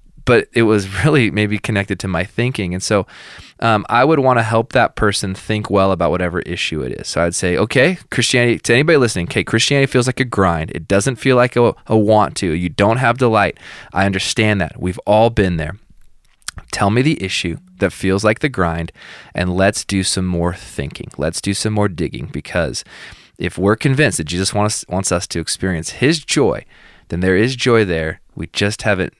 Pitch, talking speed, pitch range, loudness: 100 Hz, 210 wpm, 90-115 Hz, -16 LUFS